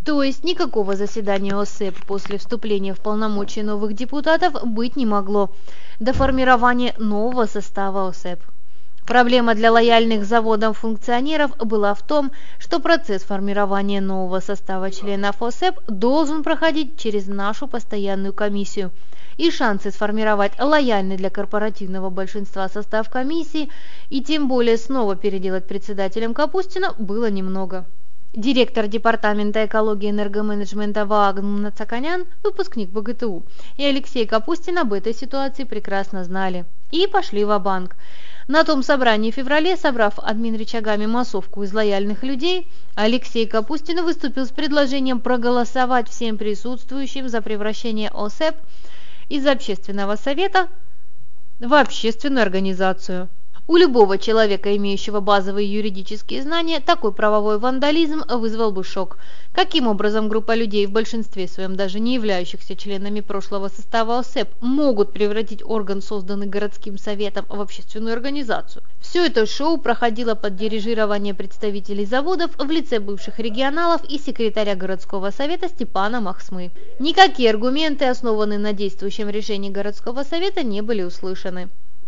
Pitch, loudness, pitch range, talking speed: 220 Hz, -21 LUFS, 205-260 Hz, 125 wpm